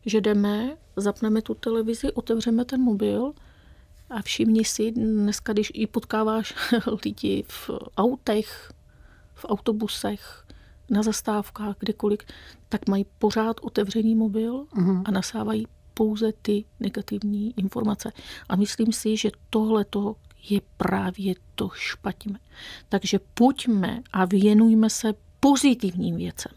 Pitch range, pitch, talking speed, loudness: 205-225 Hz, 220 Hz, 115 wpm, -25 LUFS